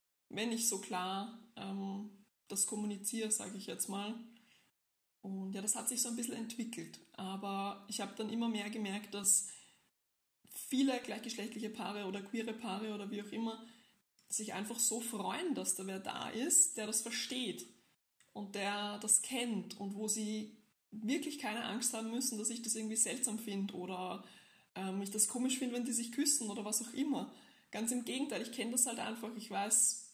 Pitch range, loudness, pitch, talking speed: 200-235 Hz, -37 LUFS, 220 Hz, 185 wpm